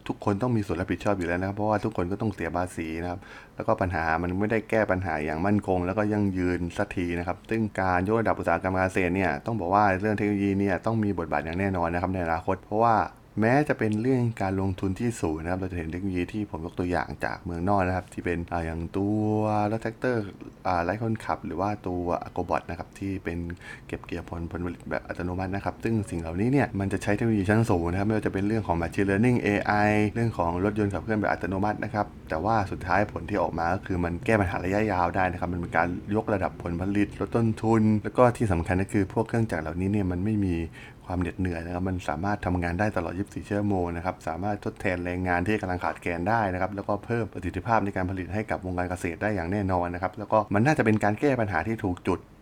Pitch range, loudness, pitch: 90-105 Hz, -27 LUFS, 95 Hz